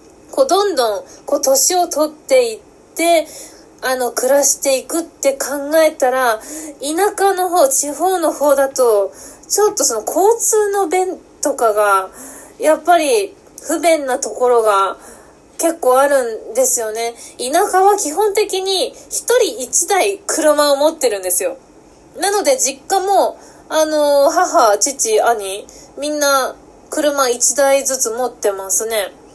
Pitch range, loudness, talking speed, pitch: 255-370 Hz, -15 LUFS, 245 characters per minute, 295 Hz